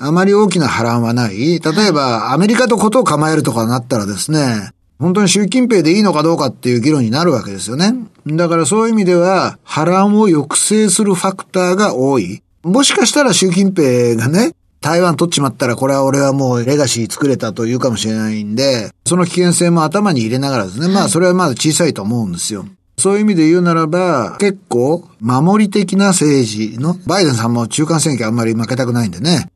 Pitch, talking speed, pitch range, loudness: 155 Hz, 430 characters per minute, 125-190 Hz, -13 LUFS